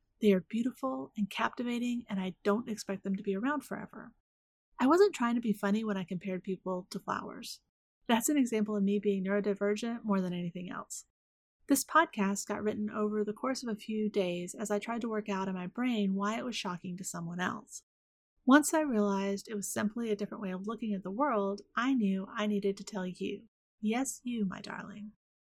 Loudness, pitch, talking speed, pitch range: -33 LUFS, 210 Hz, 210 wpm, 195-235 Hz